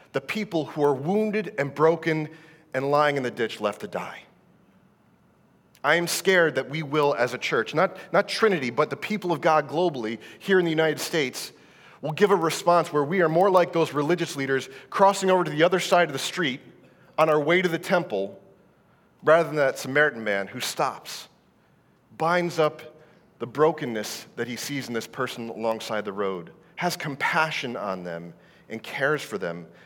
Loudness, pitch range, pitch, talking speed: -24 LUFS, 130-175 Hz, 155 Hz, 185 wpm